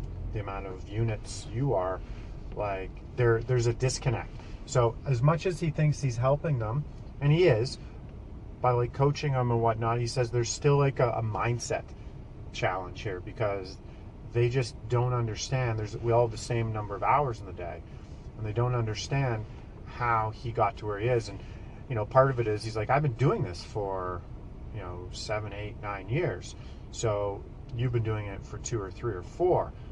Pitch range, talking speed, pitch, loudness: 105-125 Hz, 195 wpm, 115 Hz, -30 LUFS